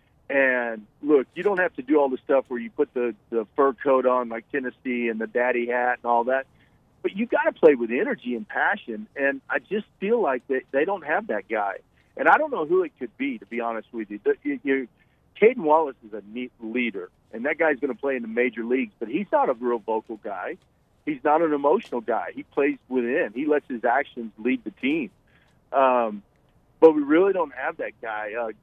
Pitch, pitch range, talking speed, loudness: 130 Hz, 120-150 Hz, 225 wpm, -24 LUFS